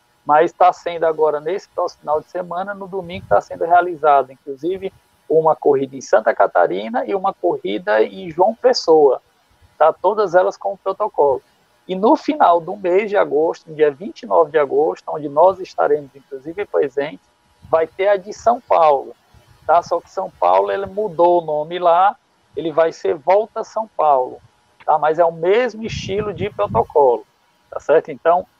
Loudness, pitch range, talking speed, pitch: -17 LUFS, 160-215 Hz, 170 wpm, 185 Hz